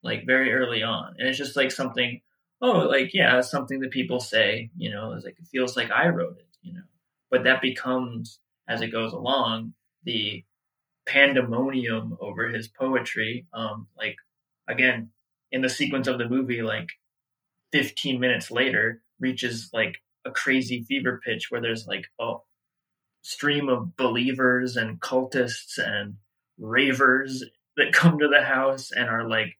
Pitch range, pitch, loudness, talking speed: 115-135 Hz, 125 Hz, -24 LUFS, 160 wpm